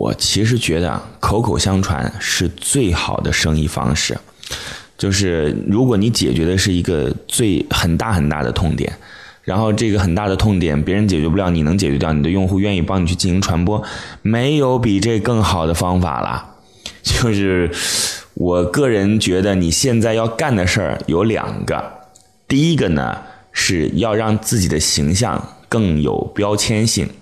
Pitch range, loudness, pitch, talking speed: 85-110 Hz, -17 LUFS, 95 Hz, 250 characters per minute